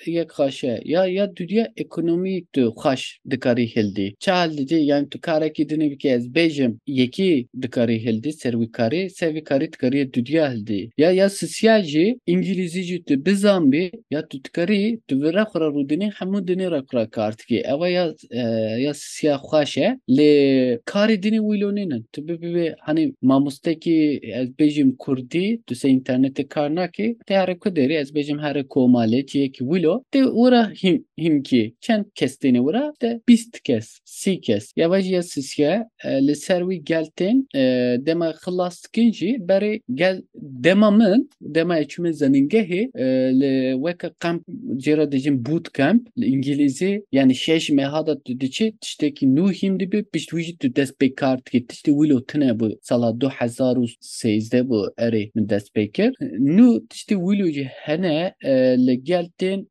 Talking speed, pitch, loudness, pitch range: 145 wpm, 160 Hz, -21 LUFS, 135-200 Hz